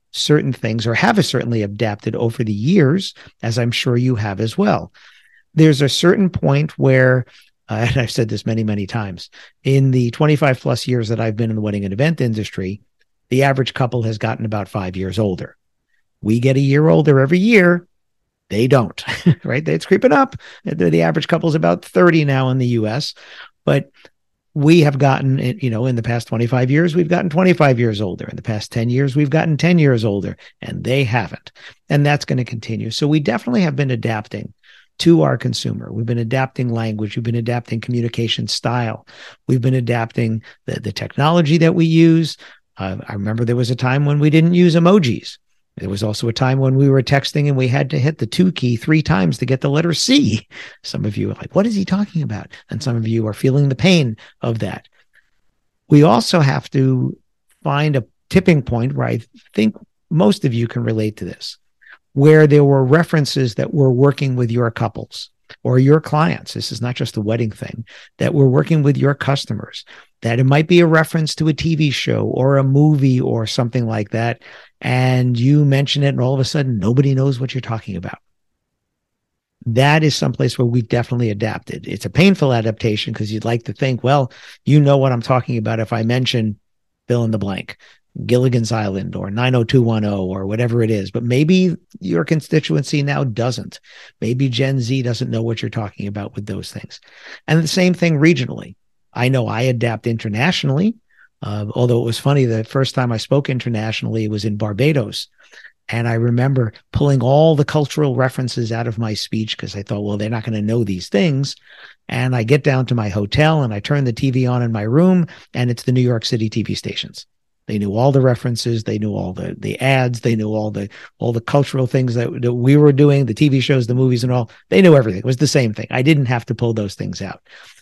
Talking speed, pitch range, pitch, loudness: 205 wpm, 115-145 Hz, 125 Hz, -17 LUFS